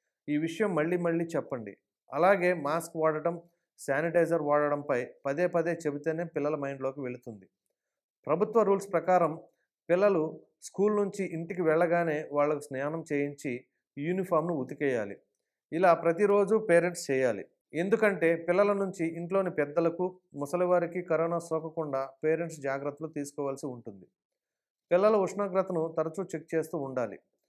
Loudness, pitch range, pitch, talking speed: -29 LUFS, 145-180 Hz, 165 Hz, 110 wpm